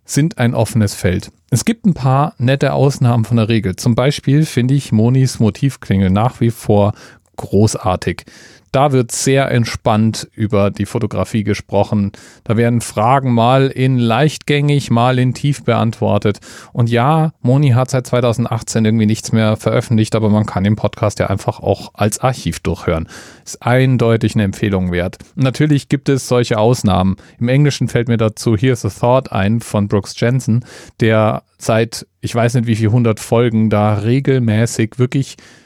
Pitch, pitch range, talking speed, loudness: 115 Hz, 105-130 Hz, 160 wpm, -15 LUFS